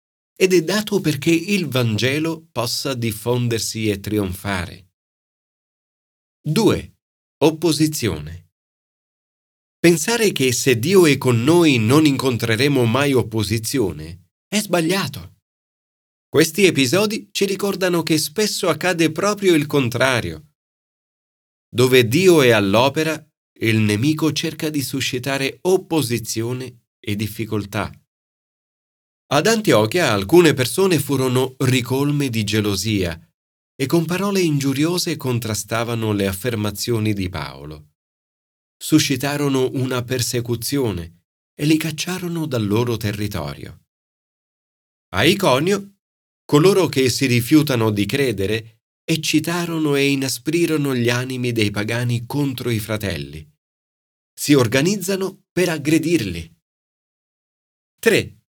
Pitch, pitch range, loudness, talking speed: 130 Hz, 105-160 Hz, -19 LUFS, 100 wpm